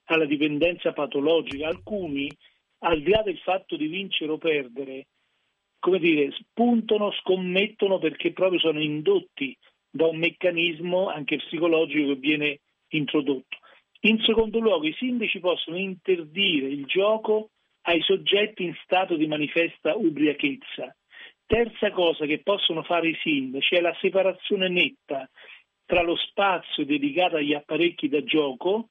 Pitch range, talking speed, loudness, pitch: 155-200 Hz, 130 wpm, -24 LUFS, 175 Hz